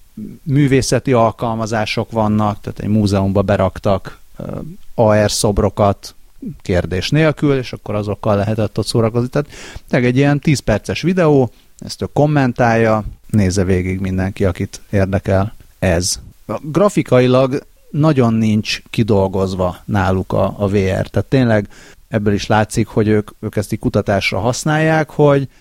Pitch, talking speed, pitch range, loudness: 110 Hz, 125 wpm, 100-130 Hz, -16 LUFS